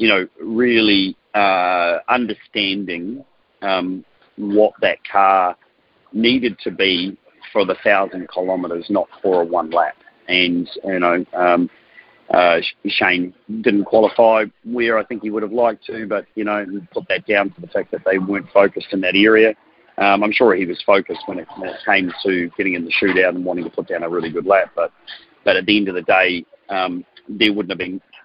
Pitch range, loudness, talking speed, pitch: 90-105 Hz, -17 LUFS, 190 wpm, 95 Hz